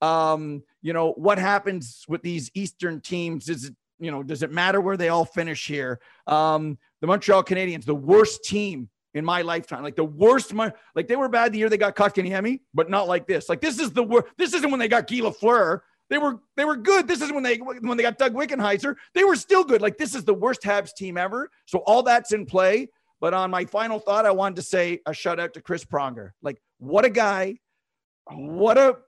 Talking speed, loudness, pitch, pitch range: 230 wpm, -23 LUFS, 195 Hz, 165-240 Hz